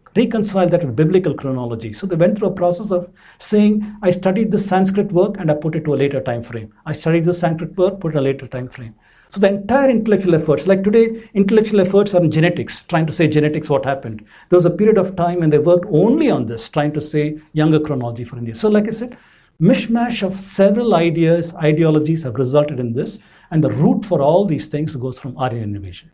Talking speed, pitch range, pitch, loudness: 225 wpm, 145-195 Hz, 170 Hz, -17 LUFS